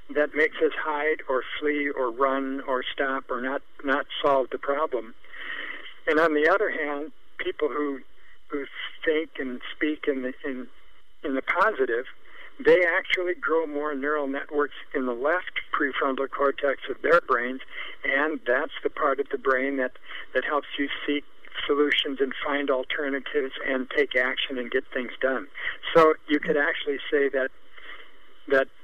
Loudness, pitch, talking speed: -26 LUFS, 145 Hz, 160 wpm